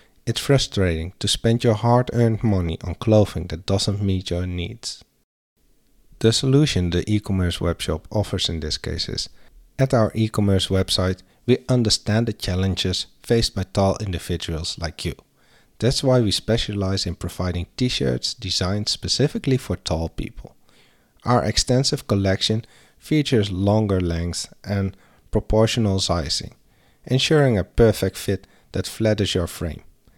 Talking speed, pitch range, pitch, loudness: 140 wpm, 90-115 Hz, 100 Hz, -22 LUFS